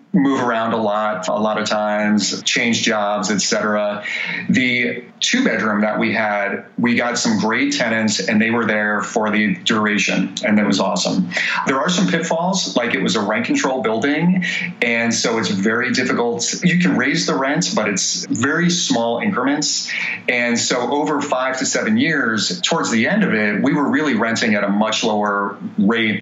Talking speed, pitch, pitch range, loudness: 185 wpm, 115 Hz, 105-150 Hz, -17 LUFS